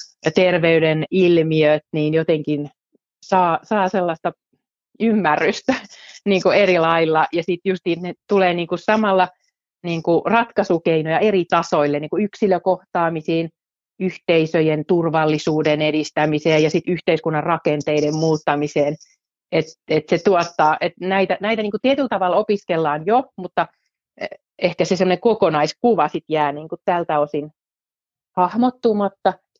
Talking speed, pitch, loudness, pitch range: 125 wpm, 175 Hz, -19 LUFS, 155-190 Hz